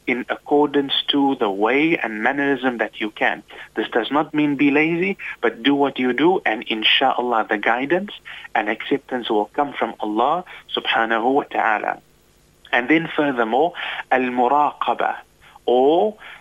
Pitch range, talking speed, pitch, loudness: 125-155 Hz, 145 wpm, 145 Hz, -20 LUFS